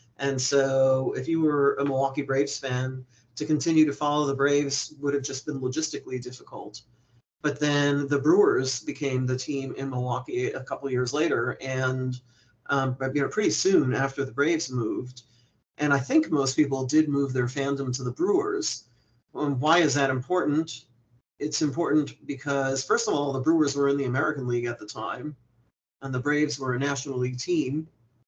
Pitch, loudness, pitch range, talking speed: 140 Hz, -26 LUFS, 125-150 Hz, 180 wpm